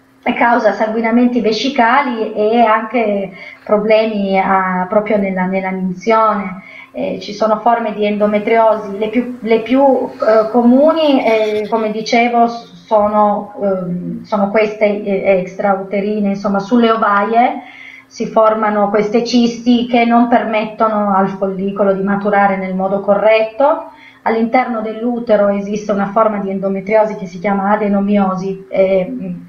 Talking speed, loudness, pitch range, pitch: 125 wpm, -14 LUFS, 200-230 Hz, 215 Hz